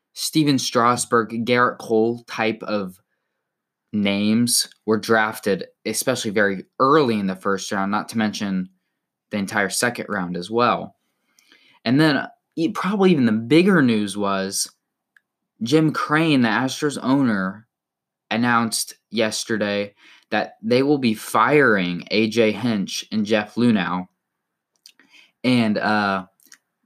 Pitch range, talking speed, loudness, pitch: 100-125 Hz, 115 wpm, -20 LUFS, 110 Hz